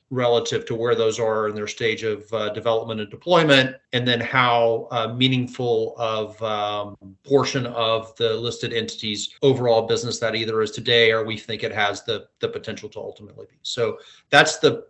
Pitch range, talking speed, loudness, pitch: 110-130 Hz, 180 wpm, -21 LUFS, 115 Hz